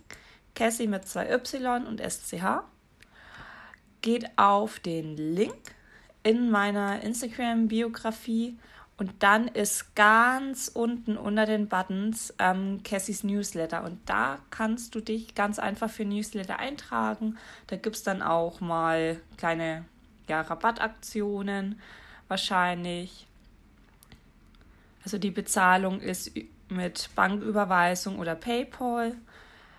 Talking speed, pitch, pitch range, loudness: 105 wpm, 205 Hz, 185-225 Hz, -28 LUFS